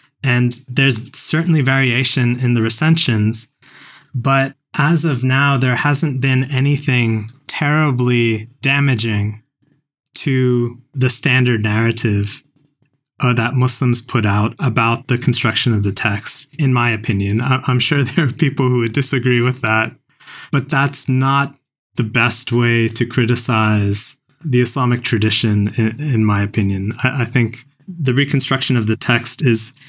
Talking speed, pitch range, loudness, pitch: 130 wpm, 115-140 Hz, -16 LUFS, 125 Hz